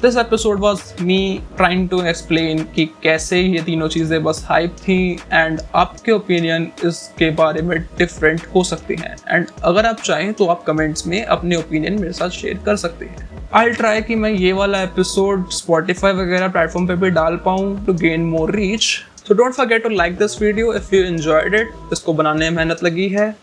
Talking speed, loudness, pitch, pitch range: 195 wpm, -17 LUFS, 180 Hz, 165-205 Hz